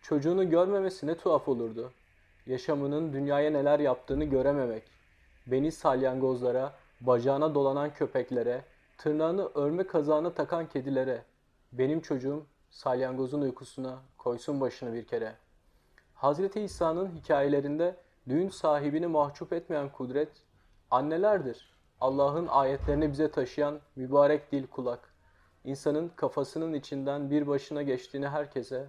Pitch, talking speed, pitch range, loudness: 140 Hz, 105 wpm, 130-155 Hz, -30 LUFS